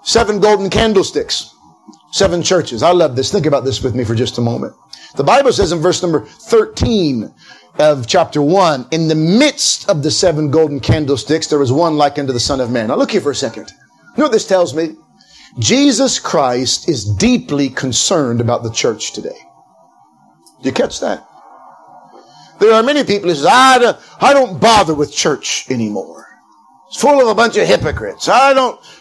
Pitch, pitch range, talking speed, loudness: 165 Hz, 140-225 Hz, 185 wpm, -13 LUFS